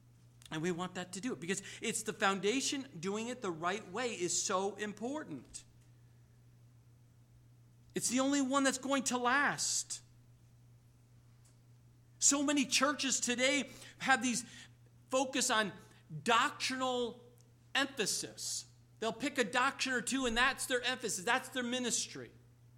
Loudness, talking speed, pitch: -34 LUFS, 130 wpm, 195 Hz